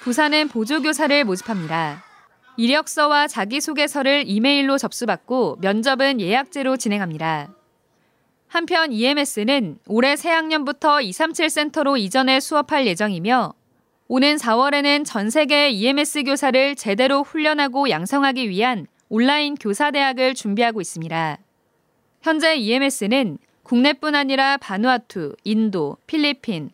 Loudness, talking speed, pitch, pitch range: -19 LUFS, 300 characters per minute, 270 Hz, 220-290 Hz